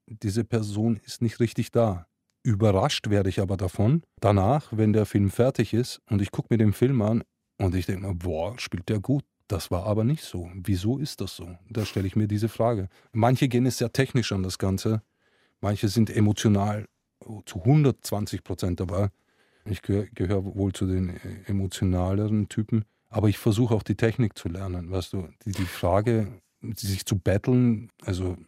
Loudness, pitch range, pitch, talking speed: -26 LUFS, 95-115 Hz, 105 Hz, 180 wpm